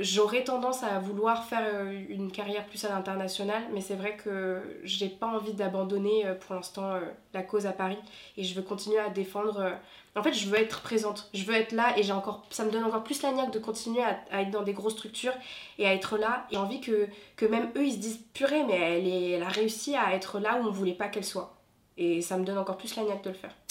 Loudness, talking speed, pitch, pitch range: -31 LUFS, 255 wpm, 205 Hz, 195-220 Hz